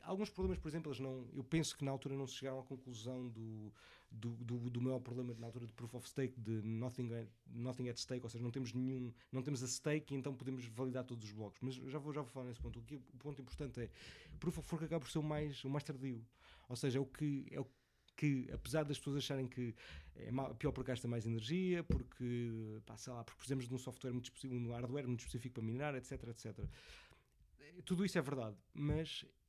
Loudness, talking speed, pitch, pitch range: -44 LUFS, 240 wpm, 130 Hz, 120-140 Hz